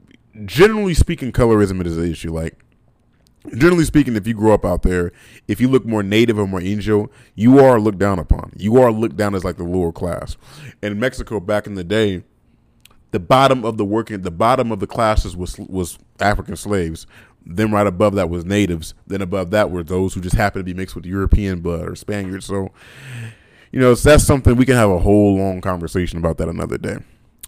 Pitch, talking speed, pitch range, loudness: 105 Hz, 210 wpm, 90-115 Hz, -17 LUFS